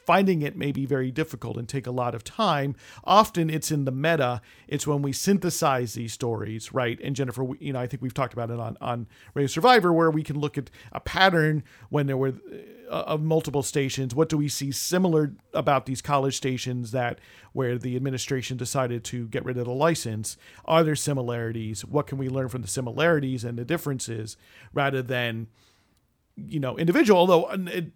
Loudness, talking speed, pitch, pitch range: -25 LUFS, 195 wpm, 135 Hz, 120-150 Hz